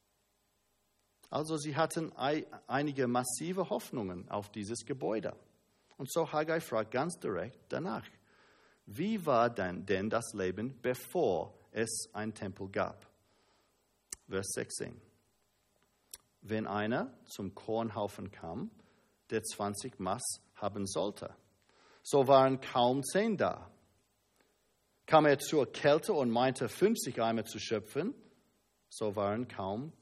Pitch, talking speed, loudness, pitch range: 115 Hz, 115 wpm, -34 LUFS, 100-145 Hz